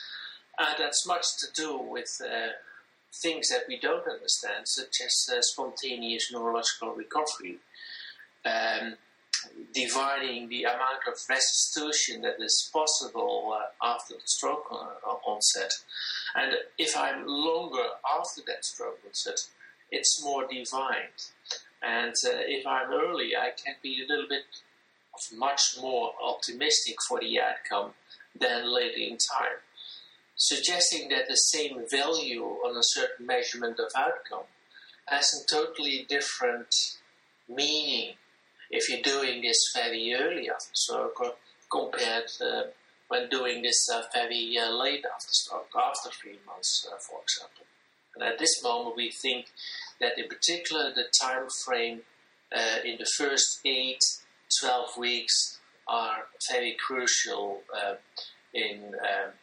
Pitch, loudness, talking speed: 140 Hz, -28 LUFS, 135 wpm